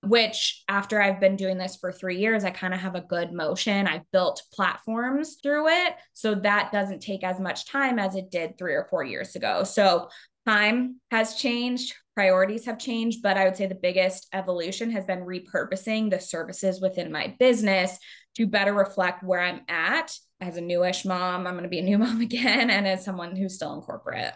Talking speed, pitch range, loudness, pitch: 205 wpm, 185-225 Hz, -25 LUFS, 195 Hz